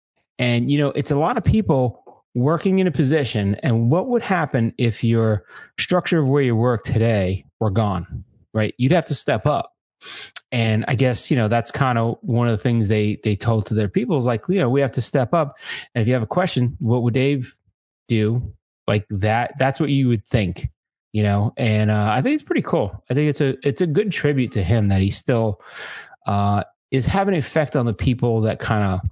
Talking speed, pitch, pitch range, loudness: 225 wpm, 120 Hz, 110-140 Hz, -20 LUFS